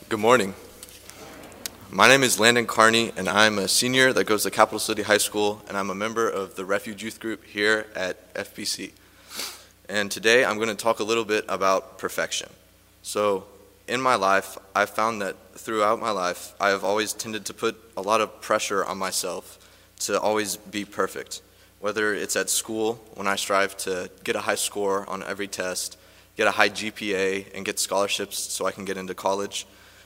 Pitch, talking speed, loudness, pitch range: 105 Hz, 190 wpm, -24 LUFS, 95-110 Hz